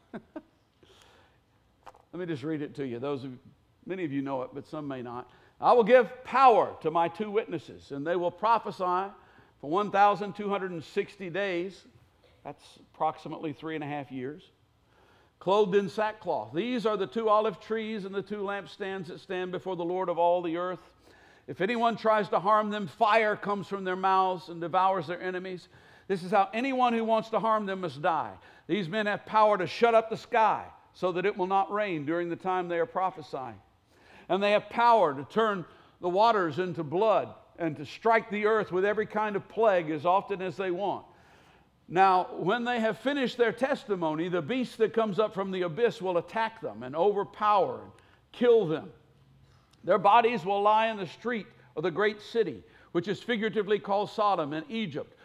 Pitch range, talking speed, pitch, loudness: 175-220 Hz, 190 wpm, 195 Hz, -28 LUFS